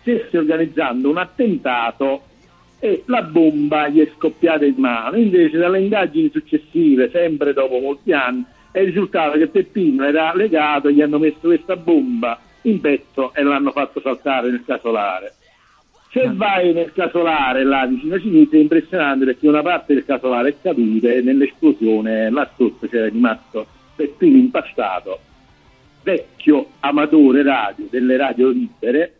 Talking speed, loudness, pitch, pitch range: 145 wpm, -17 LUFS, 155 Hz, 135-195 Hz